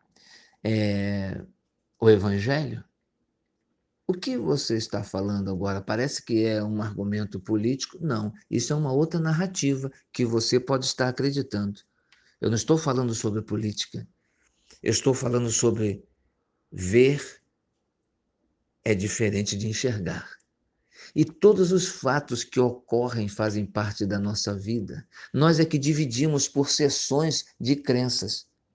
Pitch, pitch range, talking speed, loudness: 120 Hz, 105-140 Hz, 125 wpm, -25 LUFS